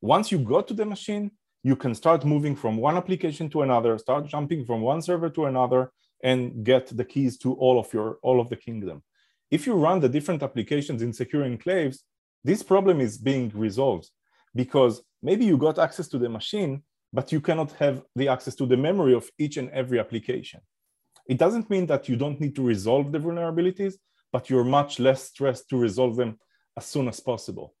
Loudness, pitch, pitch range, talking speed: -25 LUFS, 135 Hz, 125-160 Hz, 200 wpm